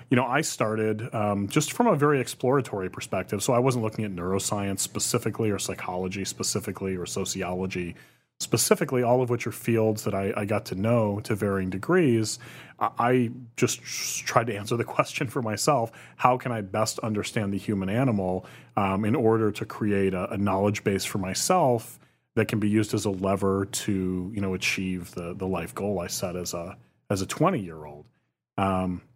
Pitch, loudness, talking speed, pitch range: 105 Hz, -26 LUFS, 185 wpm, 95-120 Hz